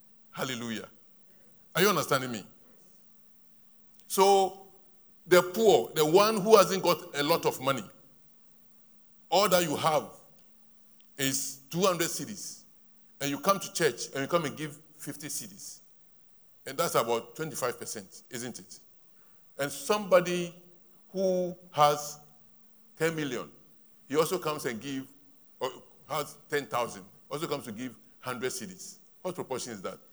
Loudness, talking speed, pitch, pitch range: -29 LUFS, 135 wpm, 170 Hz, 140-195 Hz